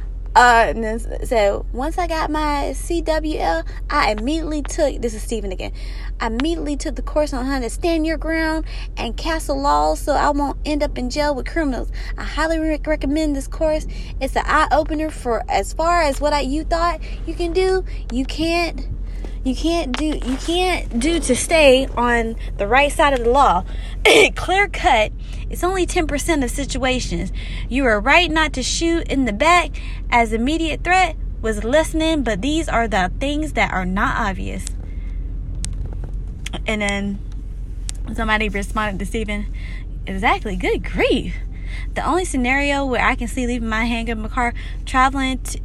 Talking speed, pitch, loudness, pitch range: 170 wpm, 280 Hz, -19 LUFS, 230-315 Hz